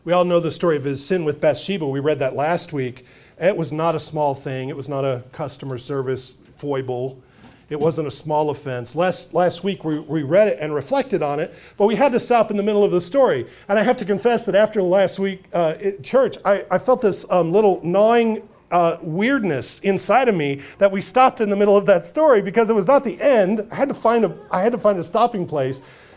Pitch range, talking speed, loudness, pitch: 150-210 Hz, 245 wpm, -19 LUFS, 180 Hz